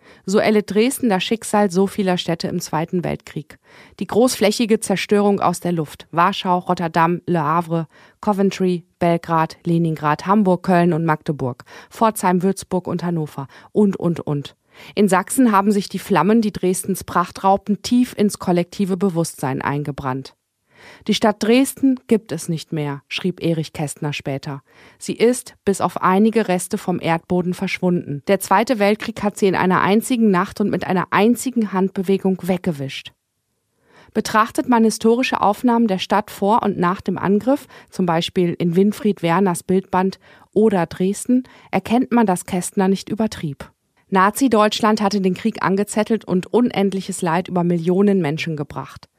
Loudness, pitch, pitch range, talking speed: -19 LUFS, 190 Hz, 175-210 Hz, 150 wpm